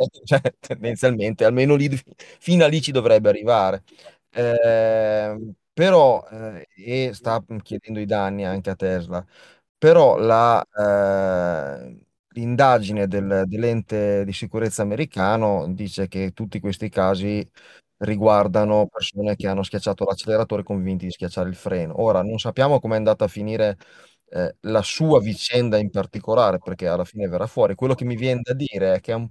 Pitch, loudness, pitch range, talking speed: 105 Hz, -20 LUFS, 100-115 Hz, 155 wpm